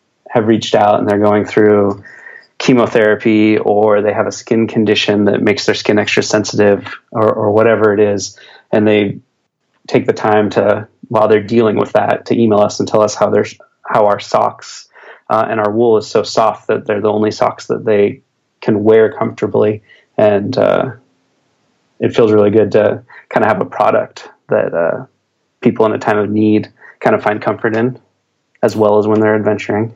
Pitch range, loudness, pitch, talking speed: 105-110 Hz, -13 LUFS, 105 Hz, 190 wpm